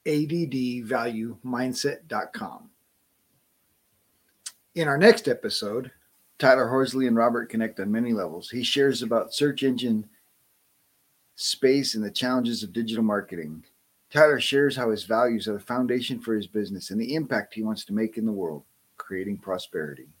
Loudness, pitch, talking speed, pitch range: -25 LUFS, 120 Hz, 145 wpm, 110-130 Hz